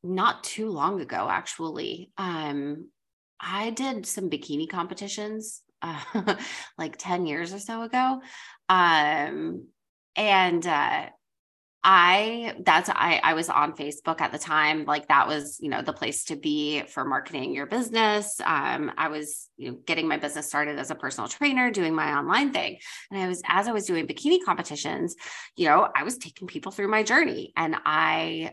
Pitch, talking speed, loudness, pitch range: 185 Hz, 170 wpm, -25 LUFS, 155-220 Hz